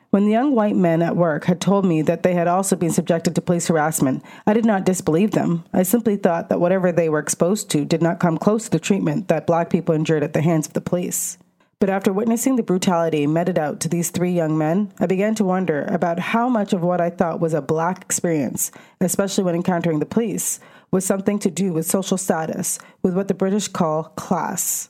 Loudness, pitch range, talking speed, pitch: -20 LUFS, 170-205 Hz, 230 wpm, 180 Hz